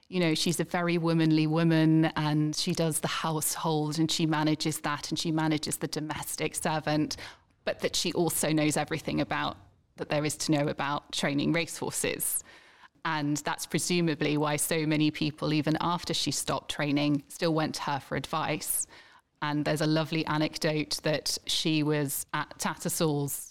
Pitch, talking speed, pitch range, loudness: 155 Hz, 165 wpm, 150-165 Hz, -29 LUFS